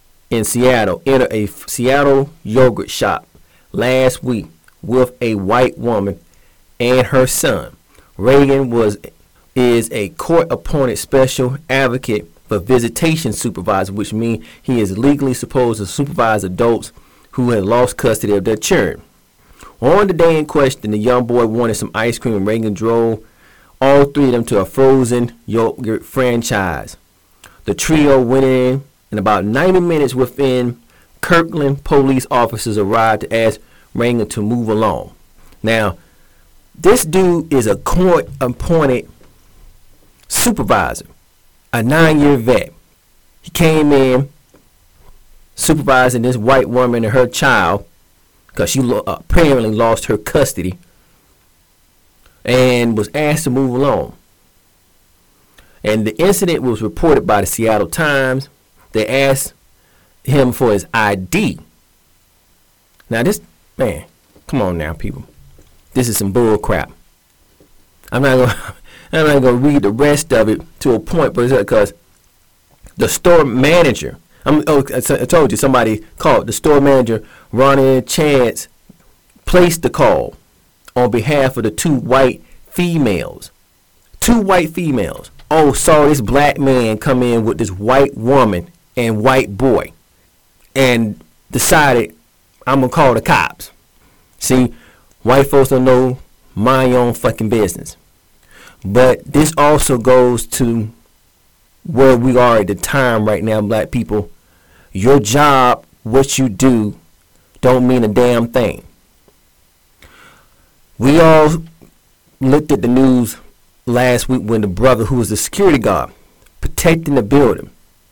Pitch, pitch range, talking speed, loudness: 120 Hz, 105-135 Hz, 135 wpm, -14 LUFS